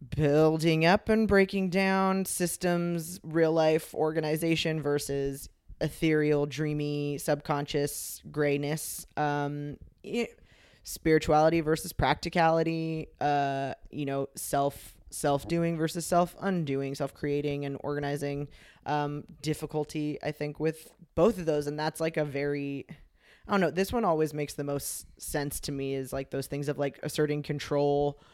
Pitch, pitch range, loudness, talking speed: 150 Hz, 145-165 Hz, -29 LUFS, 130 wpm